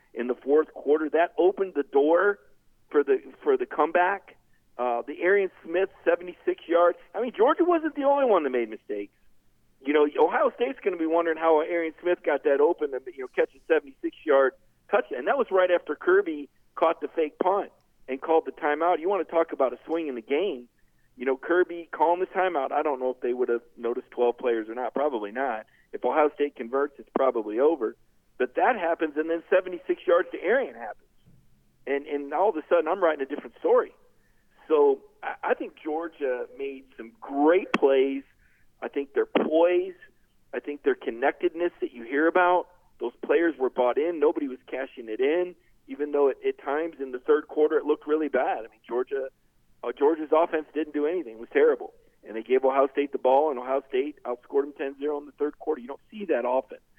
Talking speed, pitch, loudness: 215 wpm, 170 Hz, -26 LUFS